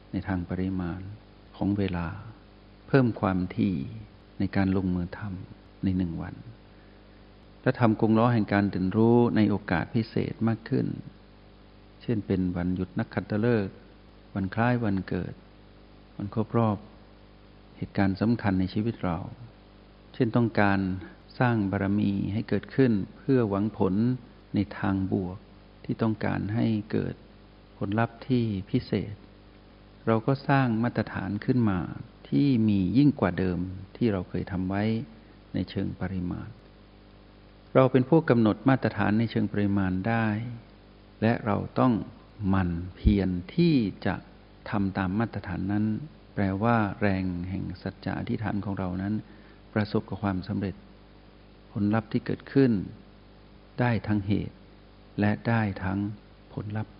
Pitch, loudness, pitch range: 105 Hz, -27 LUFS, 95-110 Hz